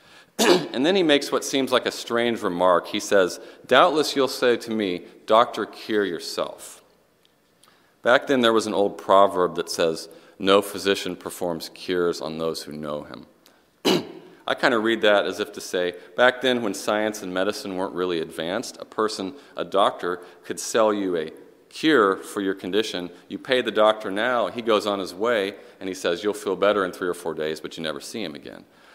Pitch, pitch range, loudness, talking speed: 100 Hz, 90-115 Hz, -23 LUFS, 195 wpm